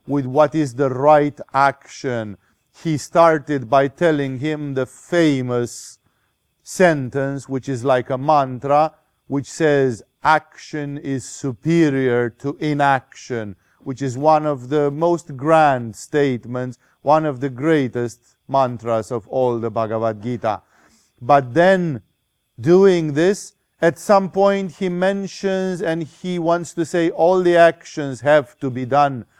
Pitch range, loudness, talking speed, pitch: 130-160 Hz, -19 LUFS, 135 wpm, 140 Hz